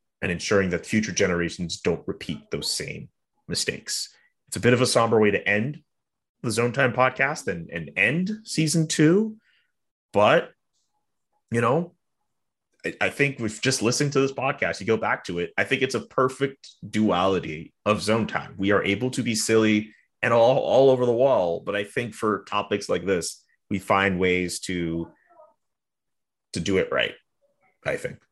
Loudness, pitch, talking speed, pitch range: -24 LUFS, 120 Hz, 175 wpm, 100-145 Hz